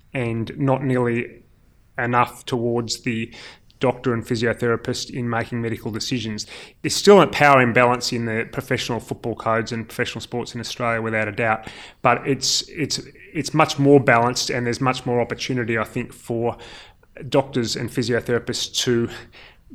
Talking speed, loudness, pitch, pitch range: 150 wpm, -21 LUFS, 120 Hz, 115-130 Hz